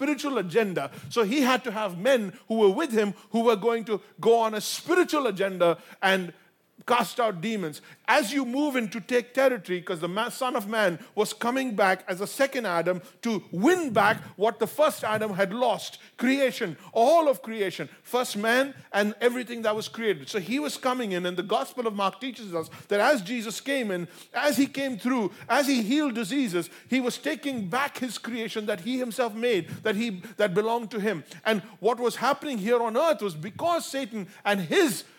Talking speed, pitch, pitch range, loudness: 200 wpm, 230 Hz, 205-255 Hz, -26 LUFS